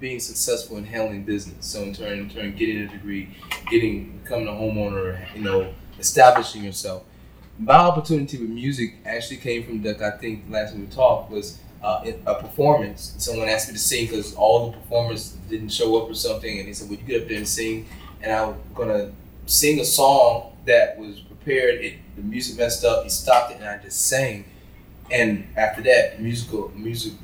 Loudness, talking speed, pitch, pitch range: -22 LUFS, 200 wpm, 110 Hz, 100-120 Hz